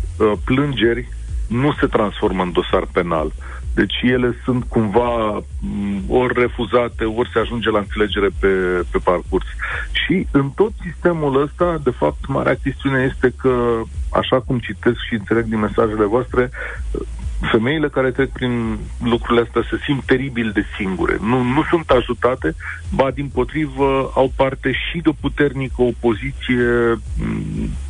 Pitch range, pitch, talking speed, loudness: 105-130 Hz, 120 Hz, 140 wpm, -19 LUFS